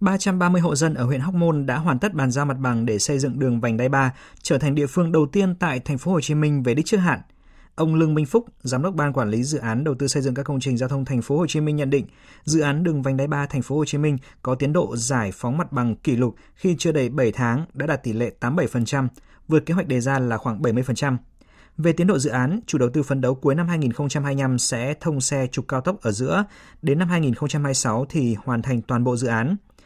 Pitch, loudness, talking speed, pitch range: 140 Hz, -22 LUFS, 265 wpm, 125-160 Hz